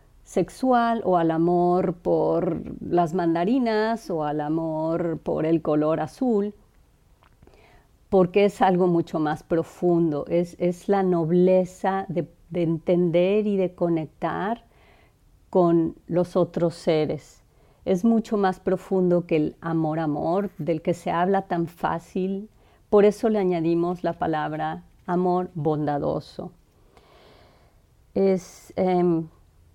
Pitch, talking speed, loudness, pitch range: 175 Hz, 115 wpm, -24 LUFS, 165-190 Hz